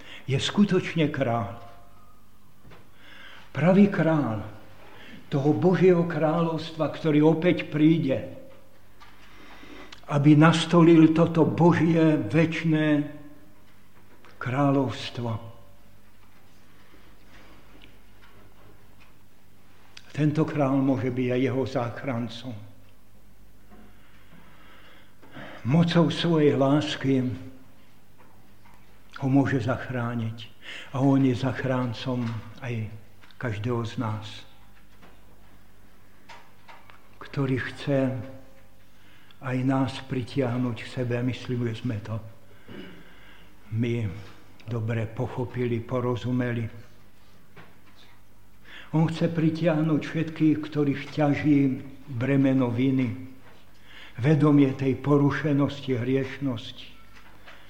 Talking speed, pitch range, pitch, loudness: 70 wpm, 105-140 Hz, 125 Hz, -25 LUFS